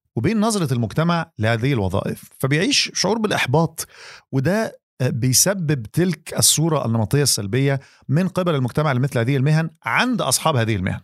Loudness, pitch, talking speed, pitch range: -19 LUFS, 145 Hz, 130 wpm, 125-170 Hz